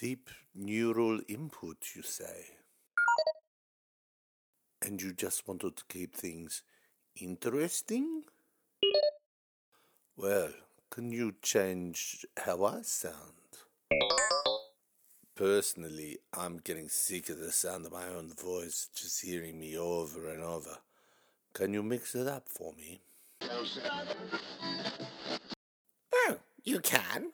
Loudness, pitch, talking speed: -35 LUFS, 95 Hz, 105 wpm